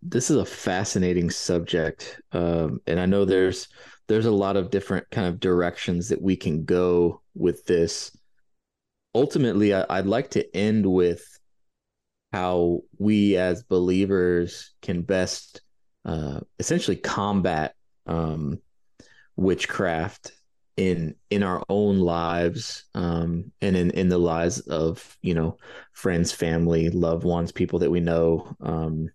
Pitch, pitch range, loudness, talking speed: 90 Hz, 85-95 Hz, -24 LUFS, 135 wpm